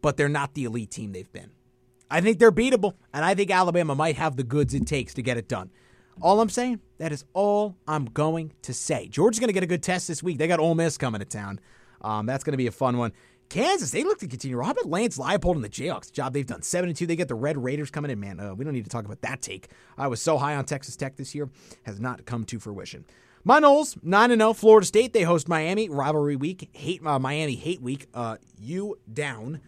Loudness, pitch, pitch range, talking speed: -25 LUFS, 150 Hz, 125-180 Hz, 255 wpm